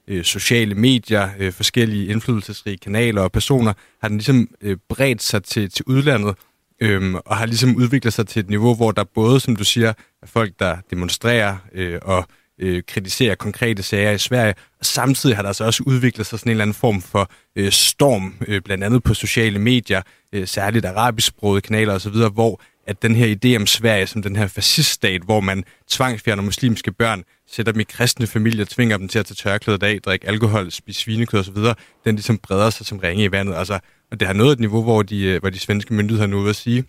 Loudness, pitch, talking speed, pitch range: -18 LUFS, 110 Hz, 200 wpm, 100-115 Hz